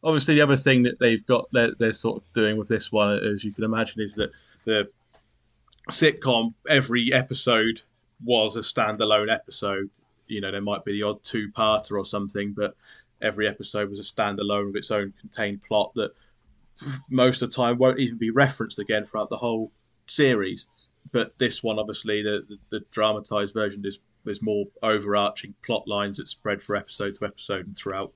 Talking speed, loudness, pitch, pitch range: 190 wpm, -24 LUFS, 110 Hz, 105-120 Hz